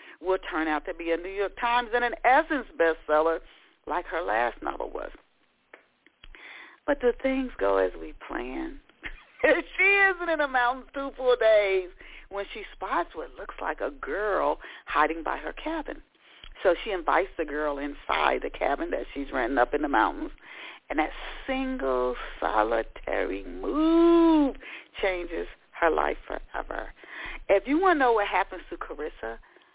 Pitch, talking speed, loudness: 245 Hz, 155 wpm, -27 LUFS